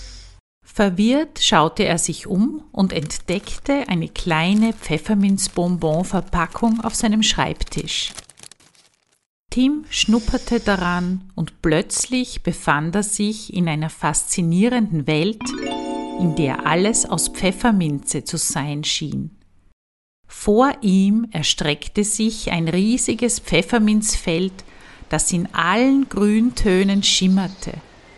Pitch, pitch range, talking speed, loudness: 185 Hz, 160-220 Hz, 95 wpm, -19 LUFS